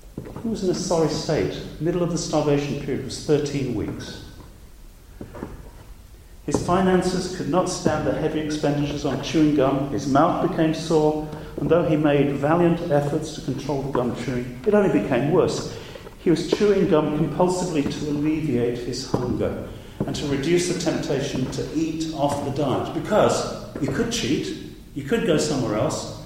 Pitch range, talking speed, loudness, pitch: 145-170 Hz, 165 wpm, -23 LUFS, 155 Hz